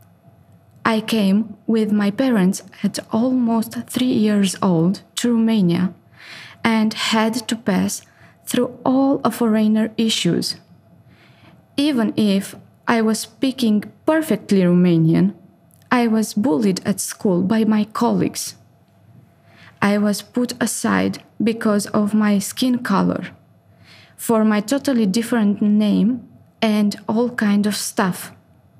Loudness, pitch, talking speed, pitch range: -19 LUFS, 220 Hz, 115 wpm, 200-235 Hz